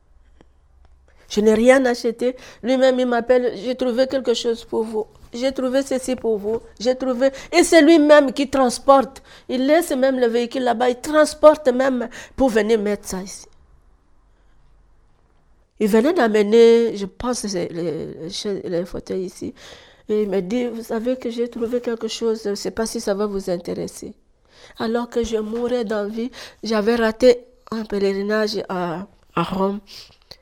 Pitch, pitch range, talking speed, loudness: 230 Hz, 205-255 Hz, 160 wpm, -19 LUFS